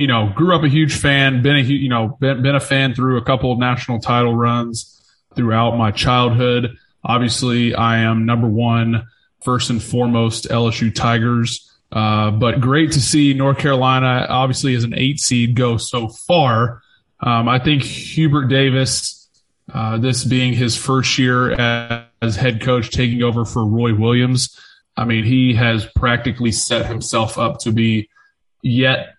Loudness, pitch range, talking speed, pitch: -16 LUFS, 115-130 Hz, 165 wpm, 120 Hz